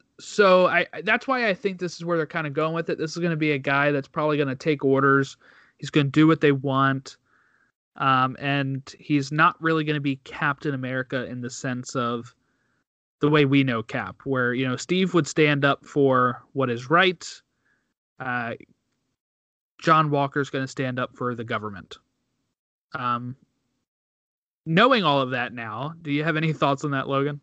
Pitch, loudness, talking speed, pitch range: 140 Hz, -23 LUFS, 195 wpm, 130-155 Hz